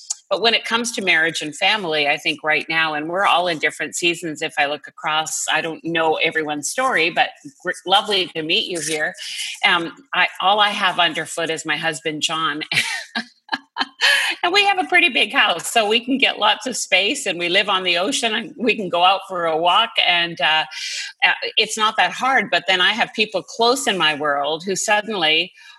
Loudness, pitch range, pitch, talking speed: -18 LUFS, 160-225 Hz, 175 Hz, 205 wpm